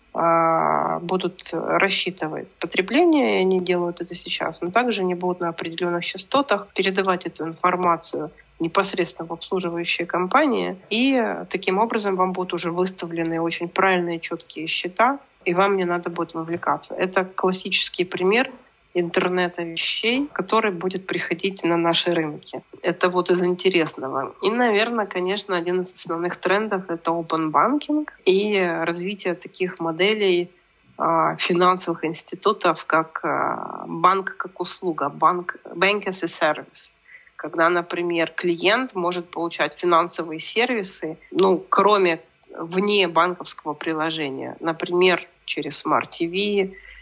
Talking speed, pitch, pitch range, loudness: 125 wpm, 180 Hz, 170-195 Hz, -22 LUFS